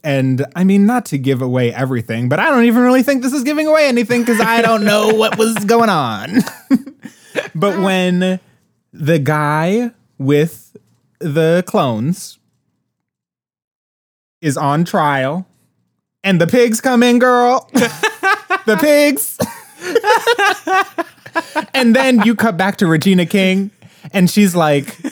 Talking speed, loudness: 135 wpm, -14 LUFS